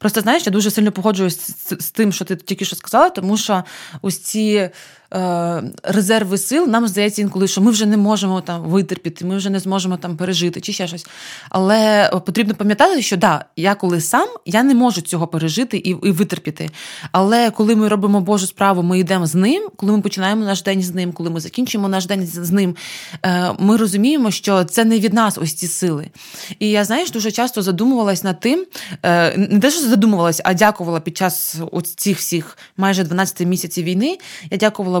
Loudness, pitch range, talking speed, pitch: -17 LUFS, 180-215 Hz, 195 wpm, 195 Hz